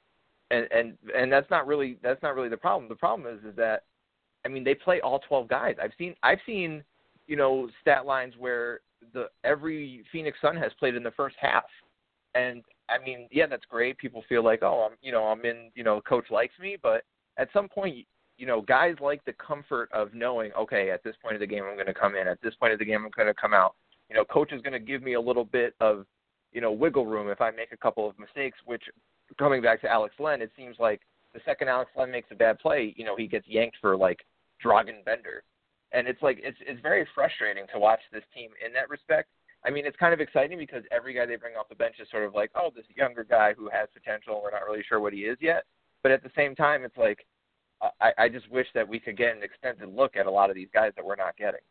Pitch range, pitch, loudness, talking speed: 110-140 Hz, 120 Hz, -27 LUFS, 255 wpm